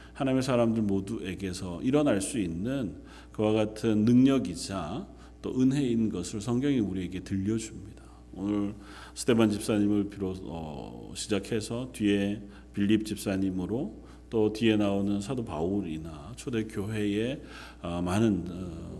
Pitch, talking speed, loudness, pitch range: 105 Hz, 280 characters per minute, -29 LUFS, 95-110 Hz